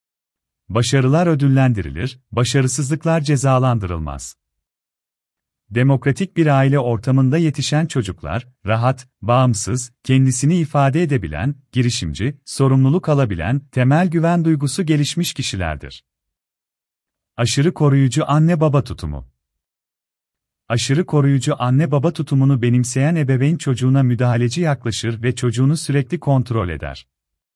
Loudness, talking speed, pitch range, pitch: -17 LUFS, 95 wpm, 100-145 Hz, 130 Hz